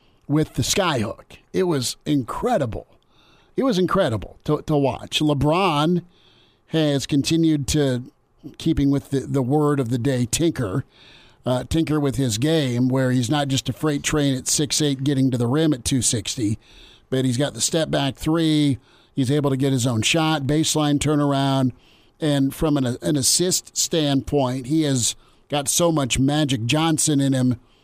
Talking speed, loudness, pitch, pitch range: 165 wpm, -21 LUFS, 140 Hz, 130-155 Hz